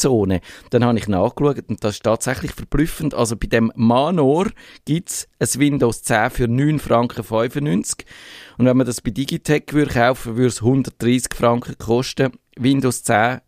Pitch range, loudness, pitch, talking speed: 115-140 Hz, -19 LUFS, 125 Hz, 170 wpm